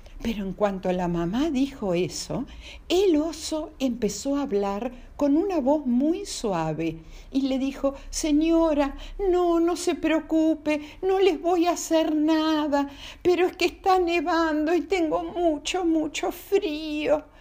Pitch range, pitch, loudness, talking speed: 275-340 Hz, 310 Hz, -25 LUFS, 145 wpm